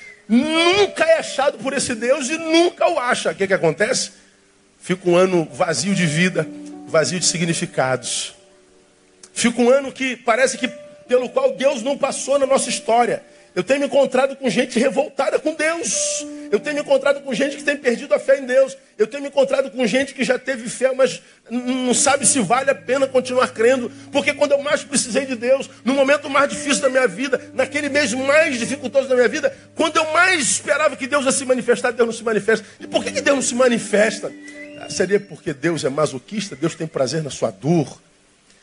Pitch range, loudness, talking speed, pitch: 210-280 Hz, -19 LUFS, 205 wpm, 255 Hz